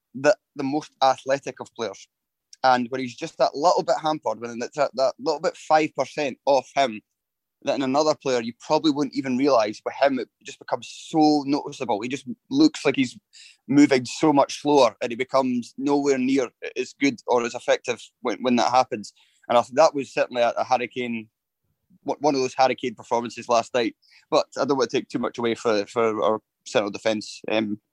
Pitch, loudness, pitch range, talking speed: 135 Hz, -23 LUFS, 120-155 Hz, 200 wpm